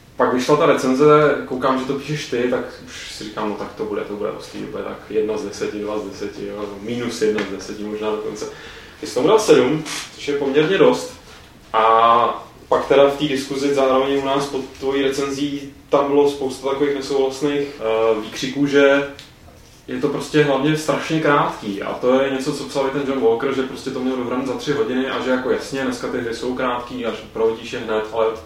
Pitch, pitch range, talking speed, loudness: 135 Hz, 120-145 Hz, 205 wpm, -19 LUFS